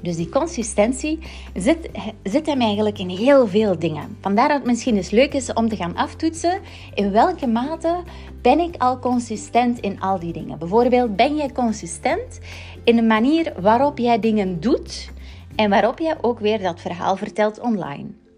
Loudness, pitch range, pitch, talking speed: -20 LUFS, 195-260 Hz, 225 Hz, 175 wpm